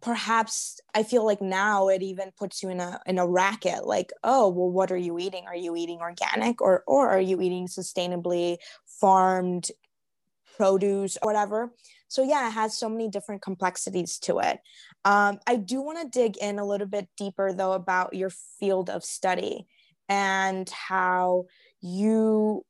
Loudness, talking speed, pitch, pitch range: -26 LUFS, 170 wpm, 195 Hz, 185-215 Hz